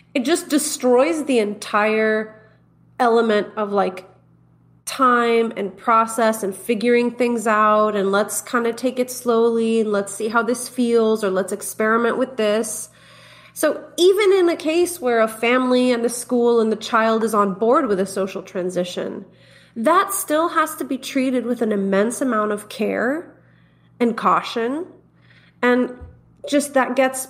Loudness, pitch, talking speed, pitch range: -19 LUFS, 230 Hz, 160 wpm, 210-255 Hz